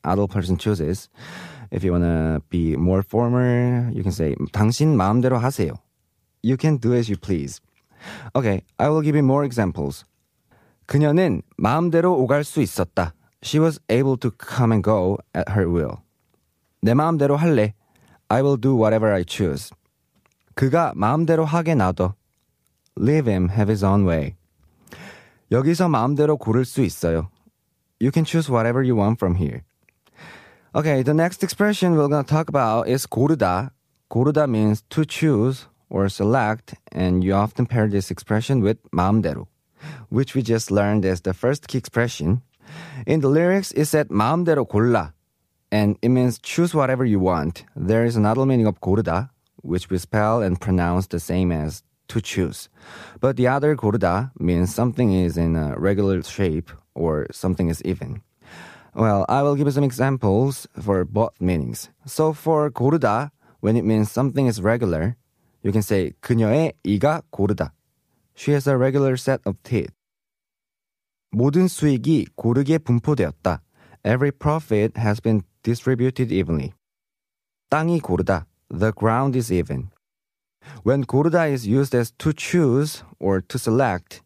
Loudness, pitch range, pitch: -21 LUFS, 95-140 Hz, 115 Hz